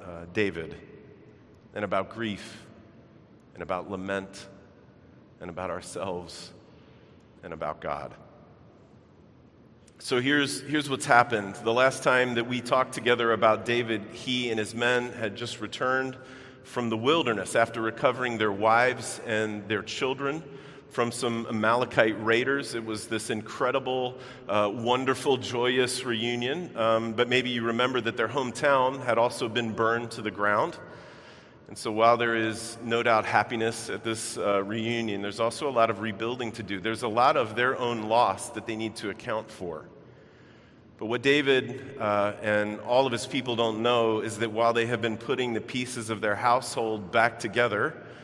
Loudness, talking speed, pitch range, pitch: -27 LUFS, 160 wpm, 110-125 Hz, 115 Hz